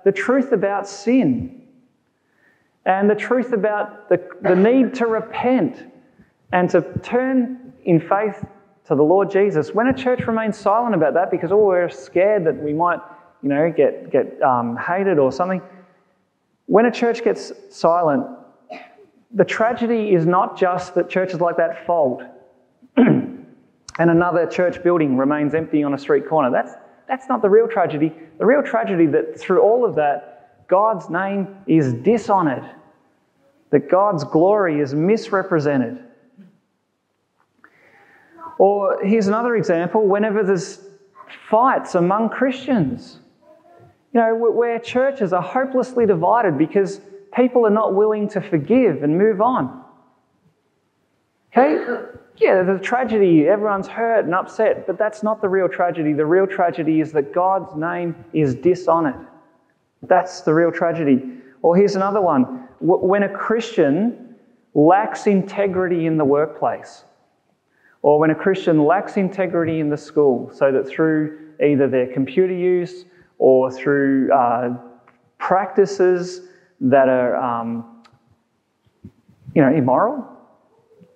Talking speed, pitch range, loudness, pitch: 135 wpm, 165-225 Hz, -18 LUFS, 190 Hz